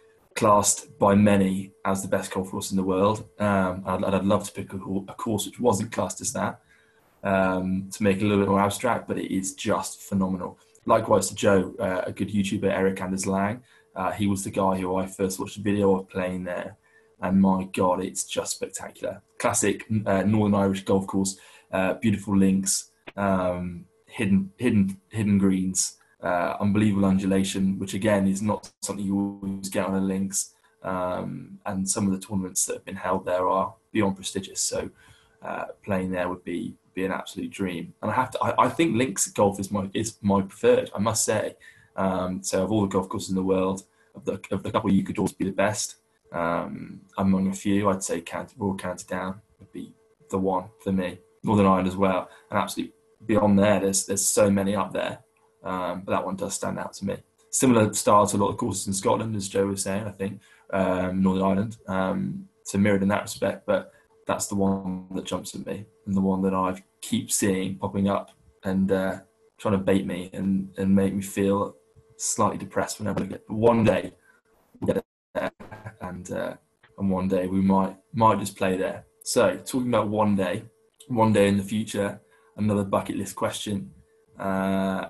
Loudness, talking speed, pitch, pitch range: -25 LUFS, 205 wpm, 95 Hz, 95-105 Hz